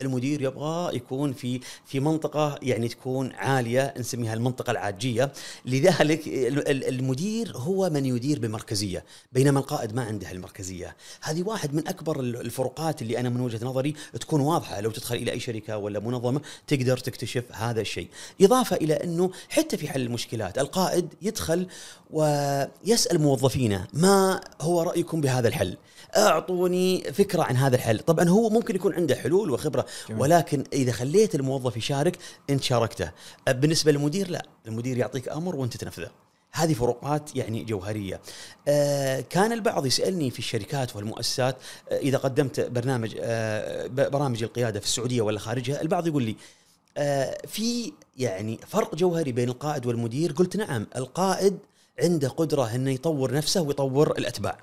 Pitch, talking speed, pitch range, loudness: 135 Hz, 145 wpm, 120-165 Hz, -26 LUFS